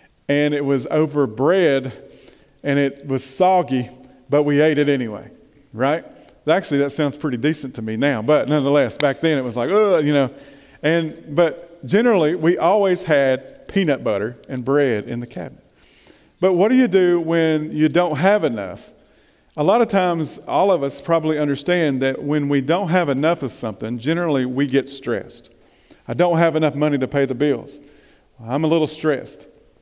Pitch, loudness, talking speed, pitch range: 145 Hz, -19 LUFS, 180 wpm, 135-165 Hz